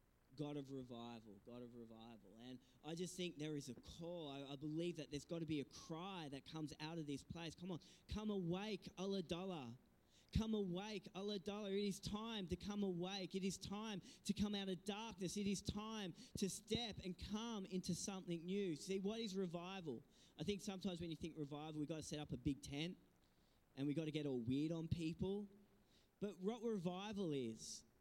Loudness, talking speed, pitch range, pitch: -48 LUFS, 205 wpm, 150-200 Hz, 175 Hz